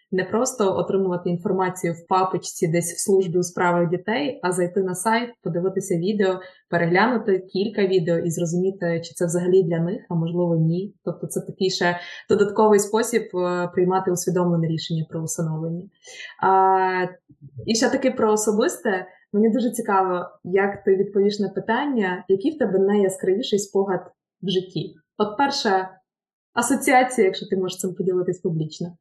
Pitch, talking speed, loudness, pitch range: 190 Hz, 150 wpm, -22 LUFS, 180-205 Hz